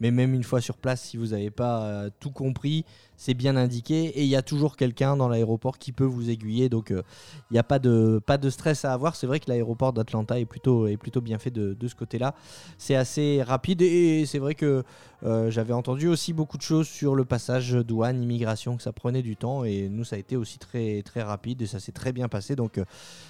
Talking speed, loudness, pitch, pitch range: 245 wpm, -26 LUFS, 125 Hz, 115-140 Hz